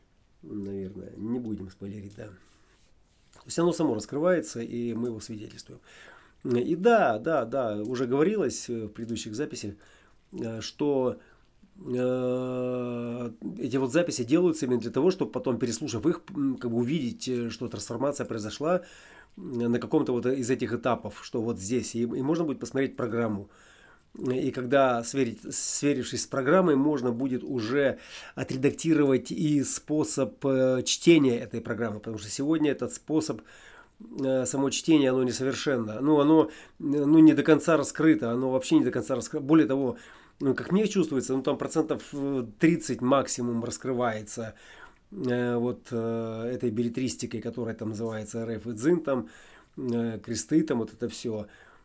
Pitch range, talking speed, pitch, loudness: 115-145 Hz, 145 wpm, 125 Hz, -27 LUFS